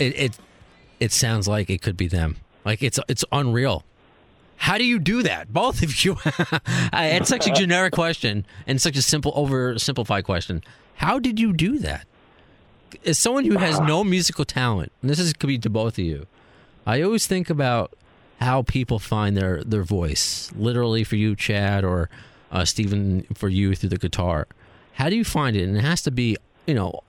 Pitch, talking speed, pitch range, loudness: 120 Hz, 195 wpm, 100-155 Hz, -22 LUFS